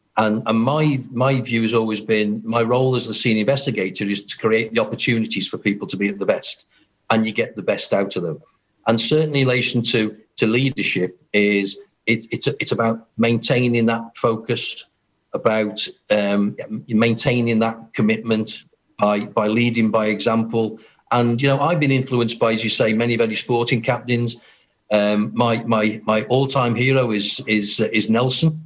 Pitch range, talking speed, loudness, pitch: 110-120 Hz, 175 wpm, -19 LUFS, 115 Hz